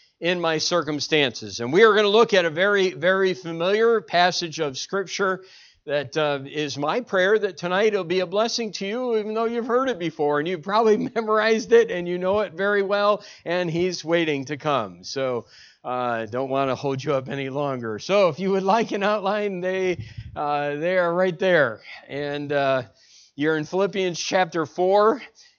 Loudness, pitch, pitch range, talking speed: -22 LUFS, 180 Hz, 145-205 Hz, 190 wpm